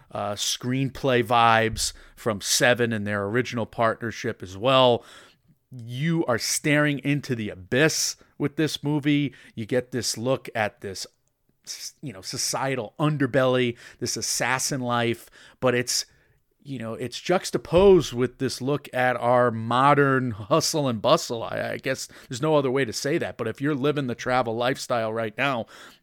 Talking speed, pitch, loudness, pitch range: 155 wpm, 125 Hz, -24 LUFS, 115-145 Hz